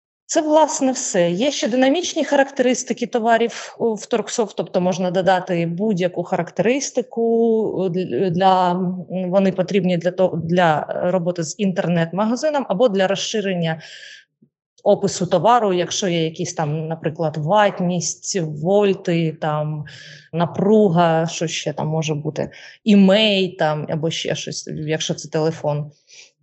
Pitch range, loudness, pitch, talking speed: 165-215 Hz, -19 LUFS, 185 Hz, 115 wpm